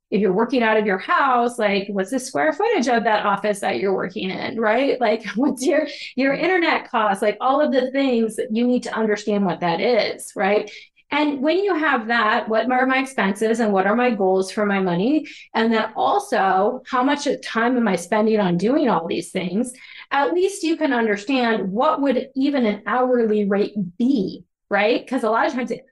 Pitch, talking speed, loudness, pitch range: 230 Hz, 210 wpm, -20 LUFS, 210-265 Hz